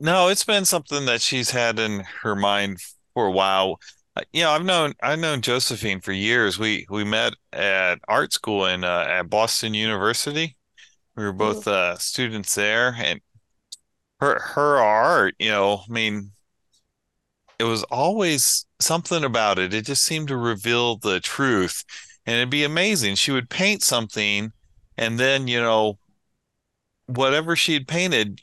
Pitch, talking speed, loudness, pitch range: 115 Hz, 160 wpm, -21 LUFS, 105-145 Hz